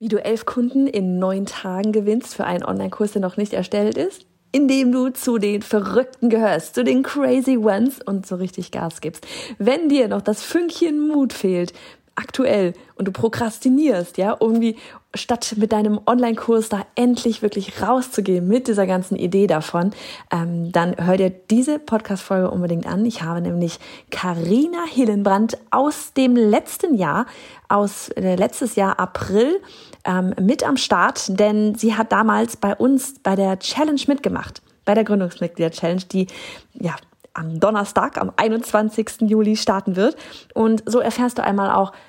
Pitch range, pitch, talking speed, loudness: 190-245 Hz, 215 Hz, 160 wpm, -20 LUFS